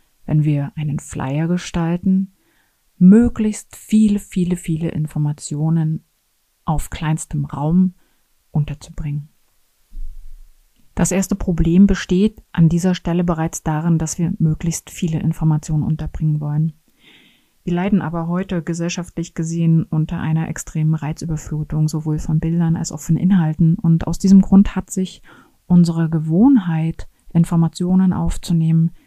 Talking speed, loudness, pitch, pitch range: 120 wpm, -18 LUFS, 165 Hz, 155-180 Hz